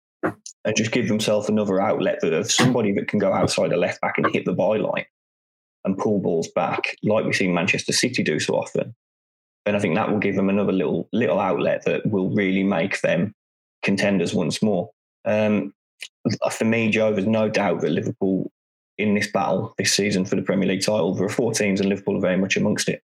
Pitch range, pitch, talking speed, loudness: 95-110 Hz, 105 Hz, 210 wpm, -22 LUFS